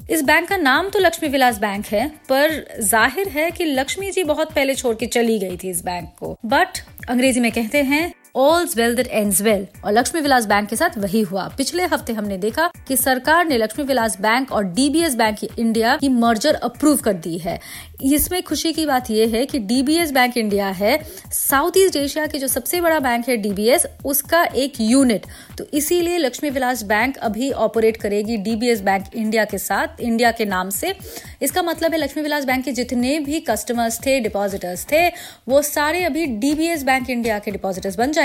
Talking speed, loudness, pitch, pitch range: 200 wpm, -19 LUFS, 255 Hz, 225-305 Hz